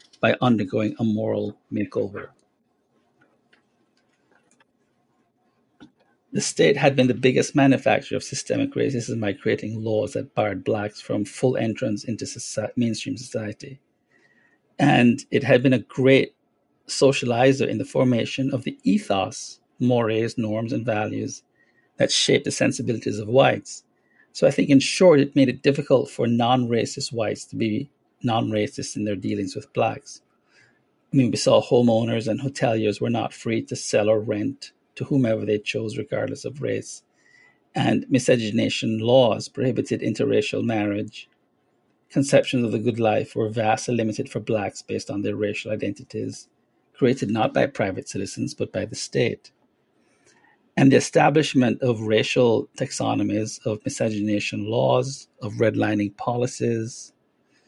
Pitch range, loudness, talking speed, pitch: 110-130 Hz, -22 LUFS, 140 wpm, 115 Hz